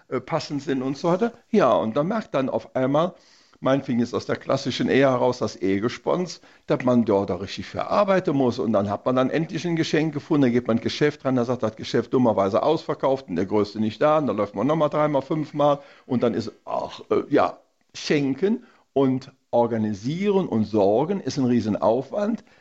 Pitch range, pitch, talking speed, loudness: 120-160 Hz, 135 Hz, 200 wpm, -23 LUFS